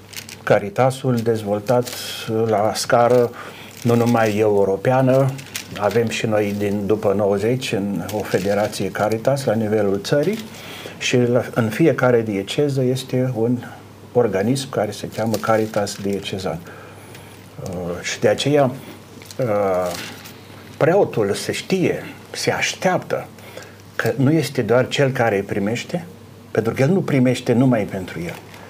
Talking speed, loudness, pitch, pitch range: 120 wpm, -20 LUFS, 115 Hz, 105-125 Hz